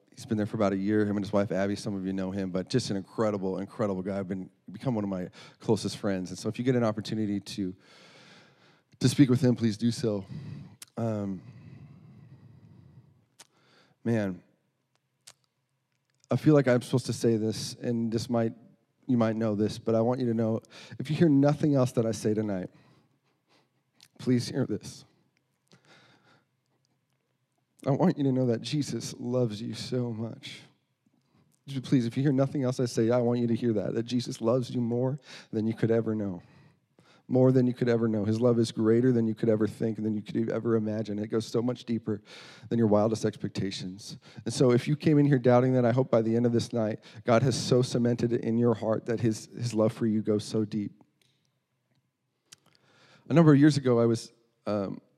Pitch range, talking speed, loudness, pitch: 110-130 Hz, 205 wpm, -28 LUFS, 115 Hz